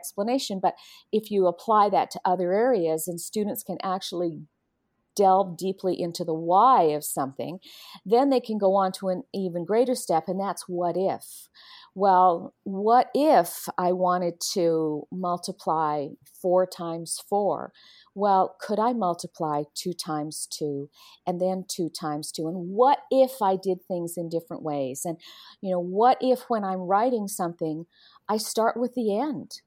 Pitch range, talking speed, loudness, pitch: 170-210 Hz, 160 wpm, -25 LUFS, 185 Hz